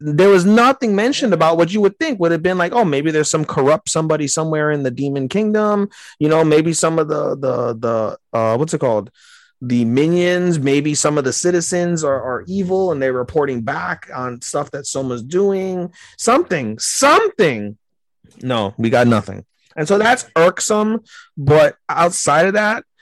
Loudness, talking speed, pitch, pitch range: -16 LUFS, 180 wpm, 160 Hz, 135-190 Hz